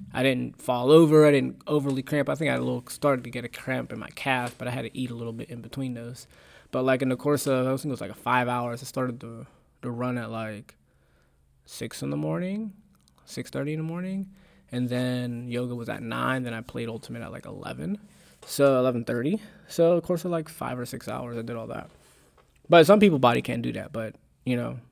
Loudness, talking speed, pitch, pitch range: -26 LUFS, 240 wpm, 125 Hz, 120-150 Hz